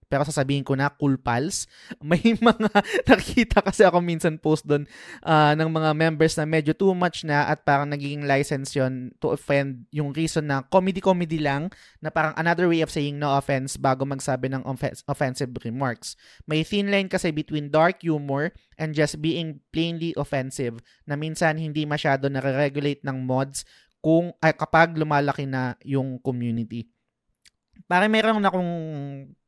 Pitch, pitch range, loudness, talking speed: 150 Hz, 140-165 Hz, -23 LUFS, 160 wpm